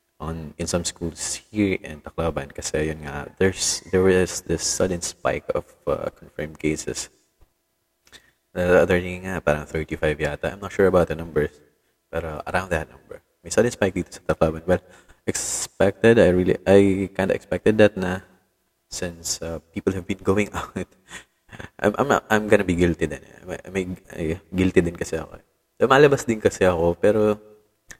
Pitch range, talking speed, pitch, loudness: 85-100 Hz, 150 wpm, 90 Hz, -22 LUFS